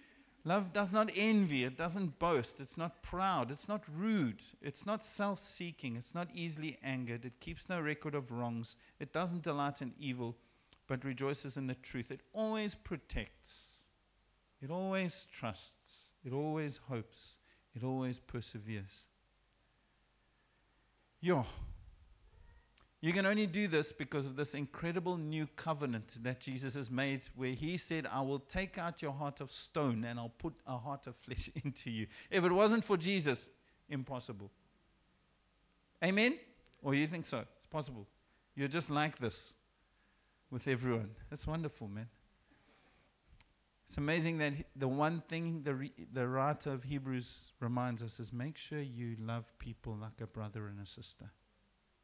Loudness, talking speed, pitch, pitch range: -39 LUFS, 155 wpm, 140 Hz, 120-165 Hz